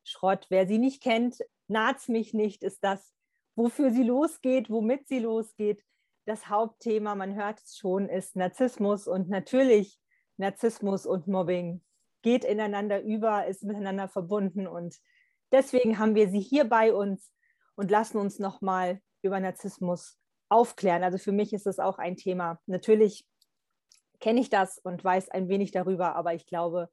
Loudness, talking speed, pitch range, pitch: -28 LUFS, 155 wpm, 190-225 Hz, 205 Hz